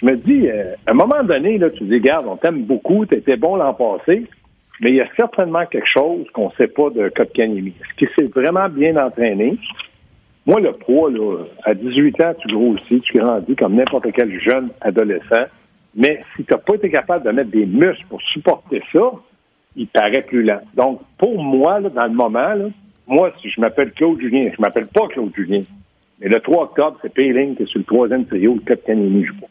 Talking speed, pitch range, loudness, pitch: 220 wpm, 115-175 Hz, -16 LUFS, 135 Hz